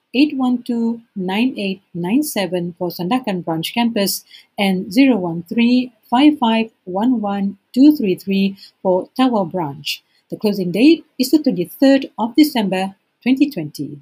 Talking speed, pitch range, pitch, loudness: 90 wpm, 185-255 Hz, 210 Hz, -18 LUFS